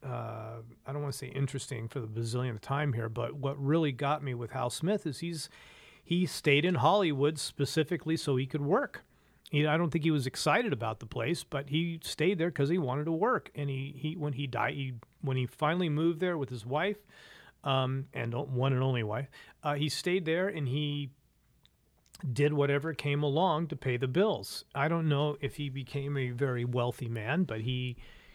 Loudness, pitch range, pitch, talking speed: -32 LUFS, 130-160 Hz, 140 Hz, 205 wpm